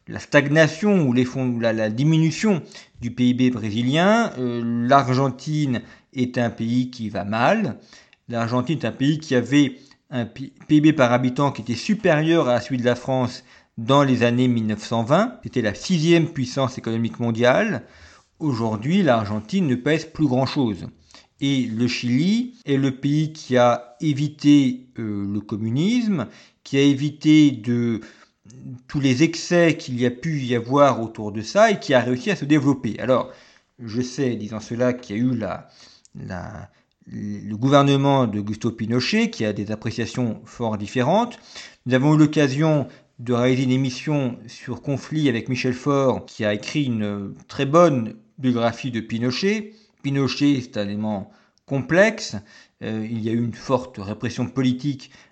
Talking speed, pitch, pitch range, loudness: 160 wpm, 125 Hz, 115-145 Hz, -21 LUFS